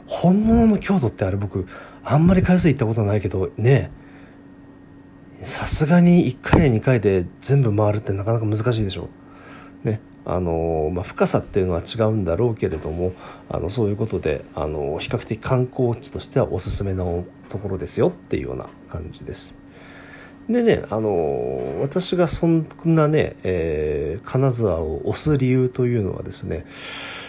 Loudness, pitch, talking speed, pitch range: -21 LUFS, 120 Hz, 315 characters per minute, 95-155 Hz